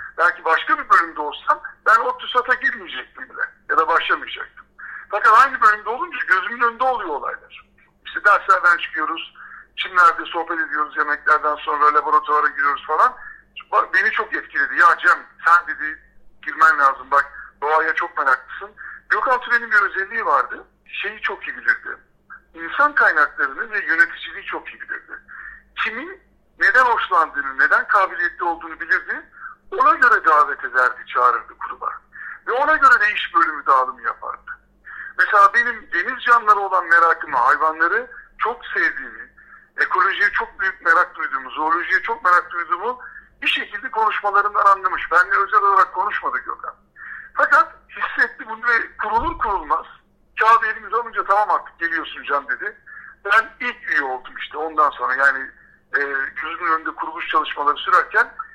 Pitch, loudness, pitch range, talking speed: 225 Hz, -18 LUFS, 180-300 Hz, 140 wpm